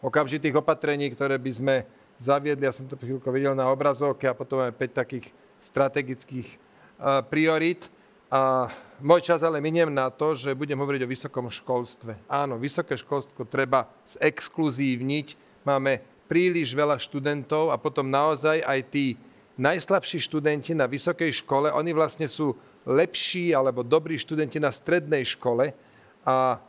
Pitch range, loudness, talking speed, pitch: 130-155 Hz, -26 LUFS, 140 wpm, 140 Hz